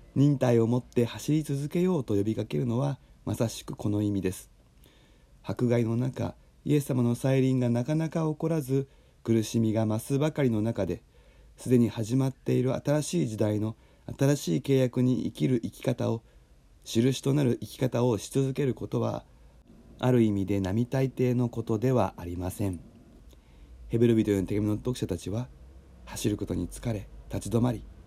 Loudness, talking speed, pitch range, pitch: -28 LUFS, 330 characters per minute, 105-130 Hz, 120 Hz